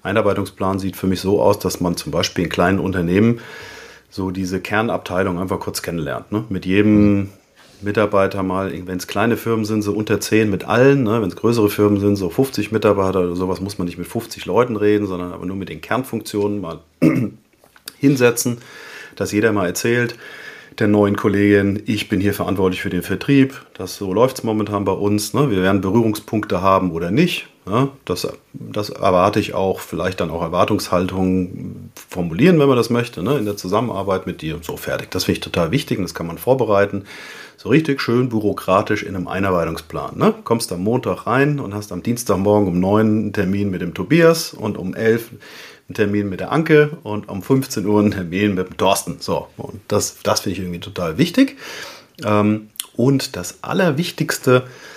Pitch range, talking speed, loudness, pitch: 95-115 Hz, 190 wpm, -18 LUFS, 105 Hz